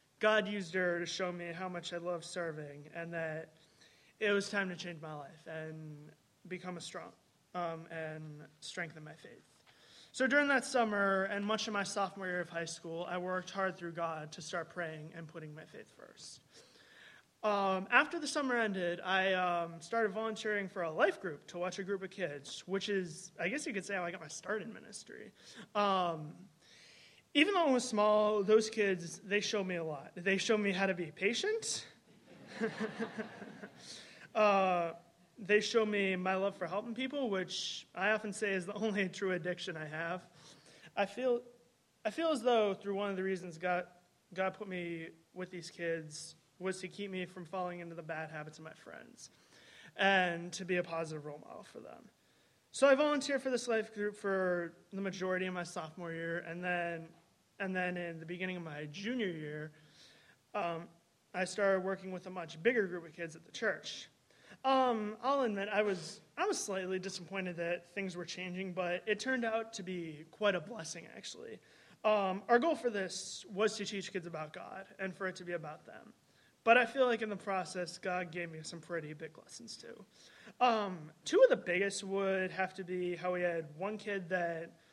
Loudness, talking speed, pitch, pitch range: -36 LUFS, 195 wpm, 185 Hz, 170-210 Hz